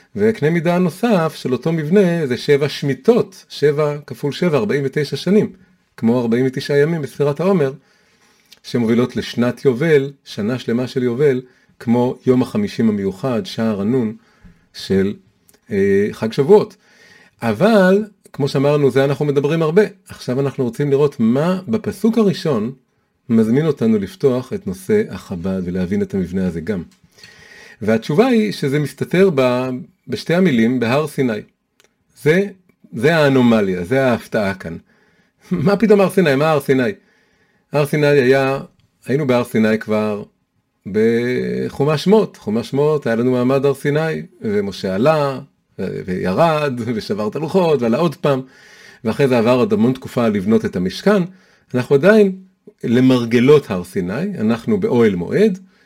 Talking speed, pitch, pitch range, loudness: 135 wpm, 150 Hz, 130-205 Hz, -17 LUFS